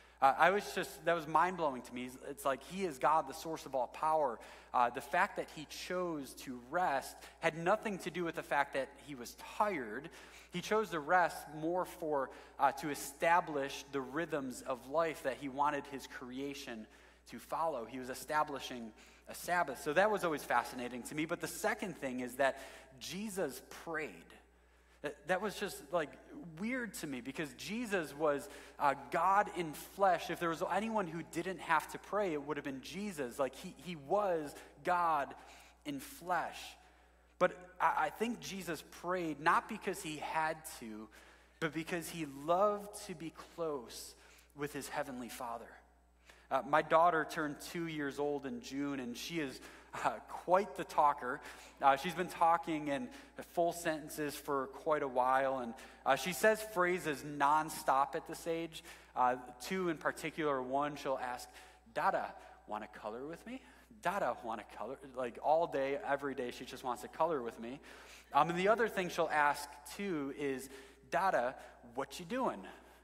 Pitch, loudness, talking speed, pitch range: 155 Hz, -37 LUFS, 175 wpm, 135-175 Hz